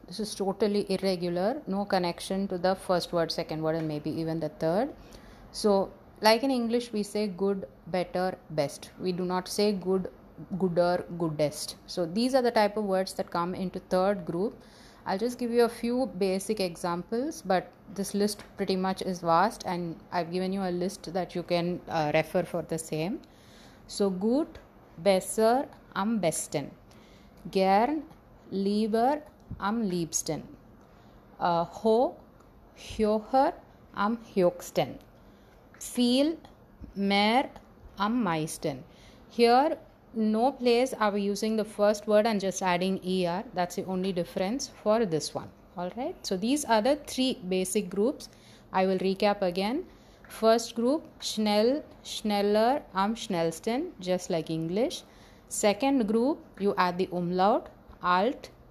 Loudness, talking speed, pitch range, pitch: -29 LUFS, 145 wpm, 180-225 Hz, 195 Hz